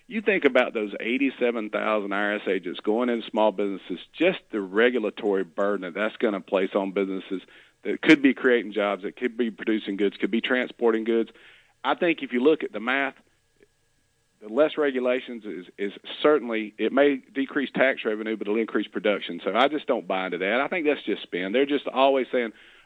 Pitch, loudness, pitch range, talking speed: 115 Hz, -25 LUFS, 105-135 Hz, 195 wpm